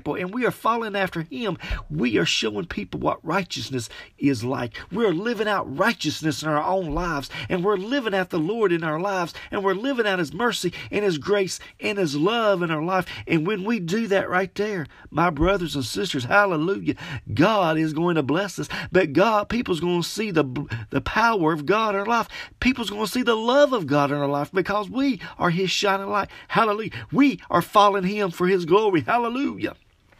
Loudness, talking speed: -23 LUFS, 210 wpm